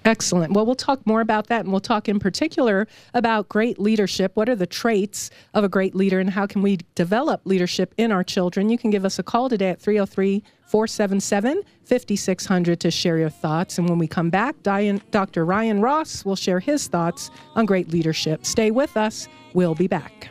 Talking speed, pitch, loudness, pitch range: 205 wpm, 200 Hz, -21 LUFS, 185-220 Hz